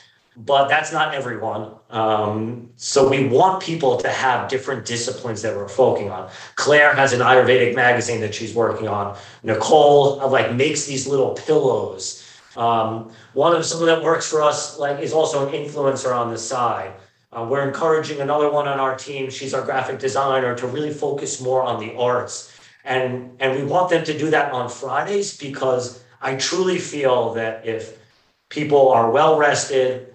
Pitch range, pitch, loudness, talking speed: 120-150 Hz, 130 Hz, -19 LUFS, 175 wpm